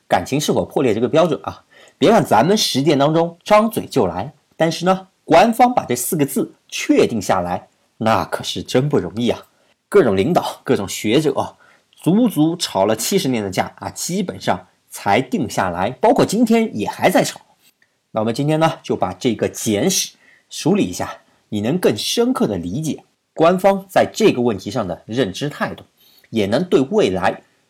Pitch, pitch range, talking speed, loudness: 180 Hz, 140-215 Hz, 260 characters per minute, -18 LUFS